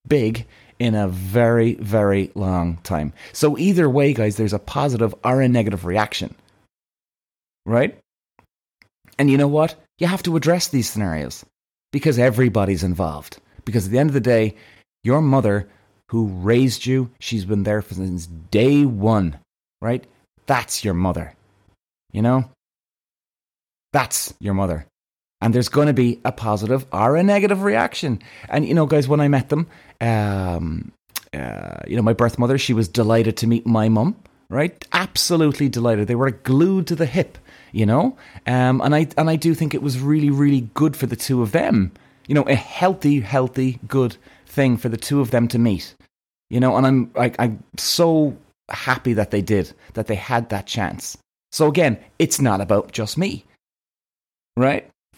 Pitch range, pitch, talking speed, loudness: 105-140 Hz, 120 Hz, 170 wpm, -20 LUFS